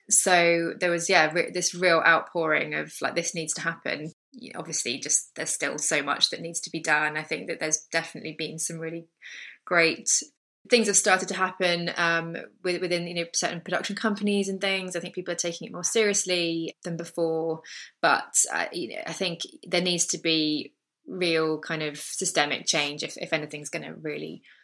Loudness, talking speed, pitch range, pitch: -25 LUFS, 200 wpm, 160-180 Hz, 170 Hz